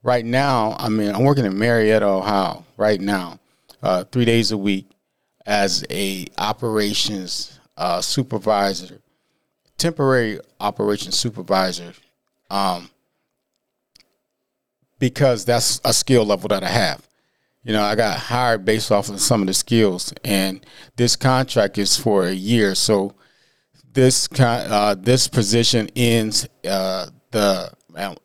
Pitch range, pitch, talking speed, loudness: 100-125 Hz, 110 Hz, 130 wpm, -19 LUFS